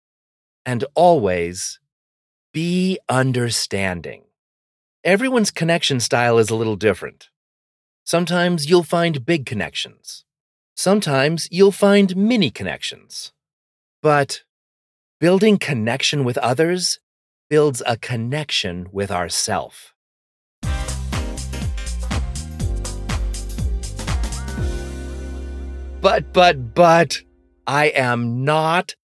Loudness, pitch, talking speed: -19 LUFS, 115 Hz, 75 wpm